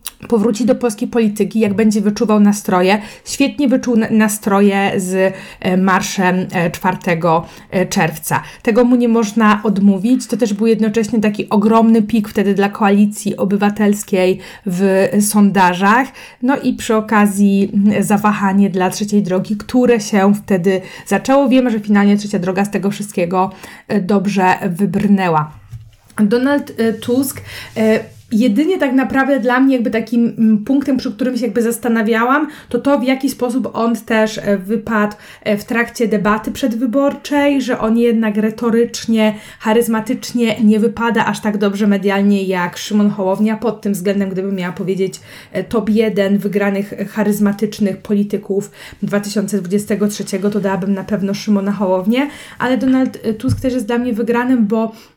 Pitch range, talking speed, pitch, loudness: 200-235 Hz, 135 wpm, 210 Hz, -15 LUFS